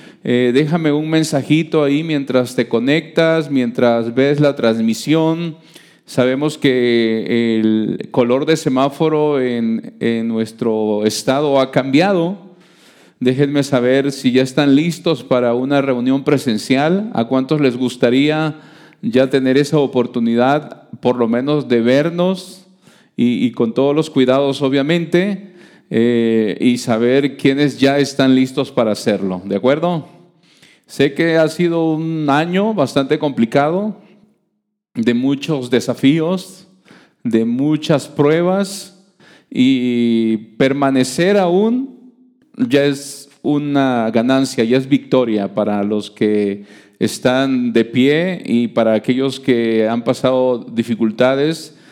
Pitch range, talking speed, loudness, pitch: 125-160 Hz, 120 wpm, -16 LUFS, 140 Hz